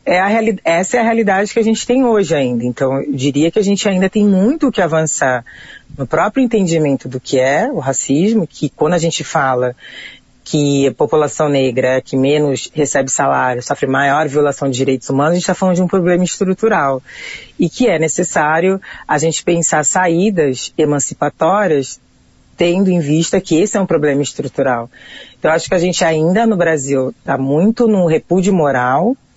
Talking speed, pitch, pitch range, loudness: 190 wpm, 160 Hz, 140-190 Hz, -14 LUFS